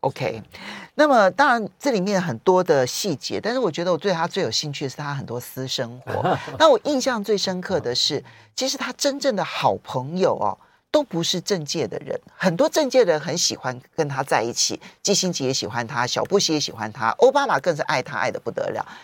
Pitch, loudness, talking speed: 180 Hz, -22 LUFS, 315 characters per minute